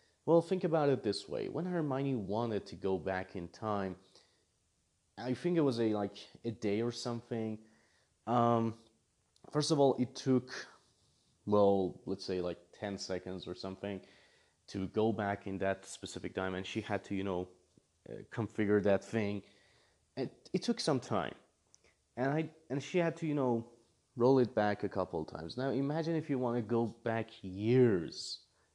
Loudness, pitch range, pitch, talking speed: -35 LUFS, 95-130 Hz, 110 Hz, 175 wpm